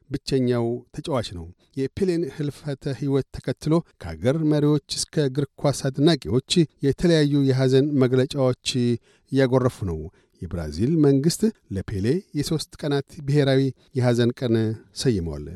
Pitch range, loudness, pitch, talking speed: 120-150 Hz, -23 LUFS, 135 Hz, 105 wpm